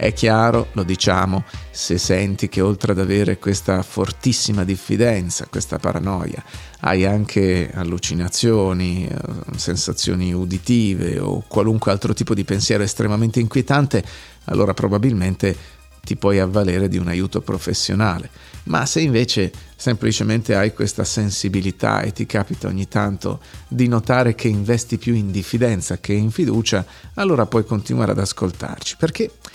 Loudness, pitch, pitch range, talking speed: -19 LUFS, 100 Hz, 95-115 Hz, 130 wpm